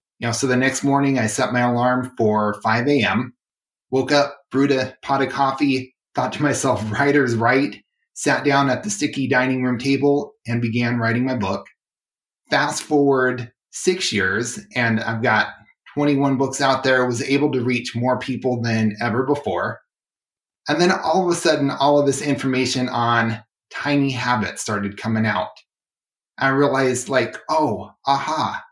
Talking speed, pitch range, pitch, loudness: 165 wpm, 120-140 Hz, 130 Hz, -20 LUFS